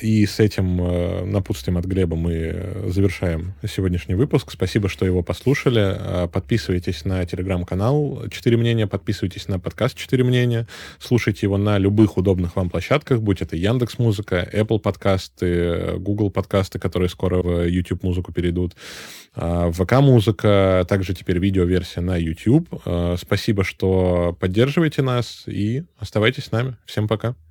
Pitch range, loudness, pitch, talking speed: 90-115 Hz, -21 LUFS, 100 Hz, 135 wpm